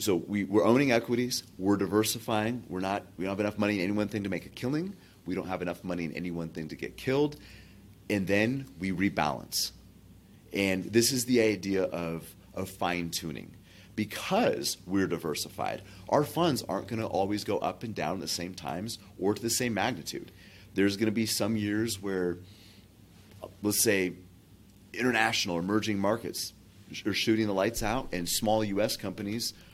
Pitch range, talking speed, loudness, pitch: 95-110 Hz, 180 wpm, -30 LUFS, 100 Hz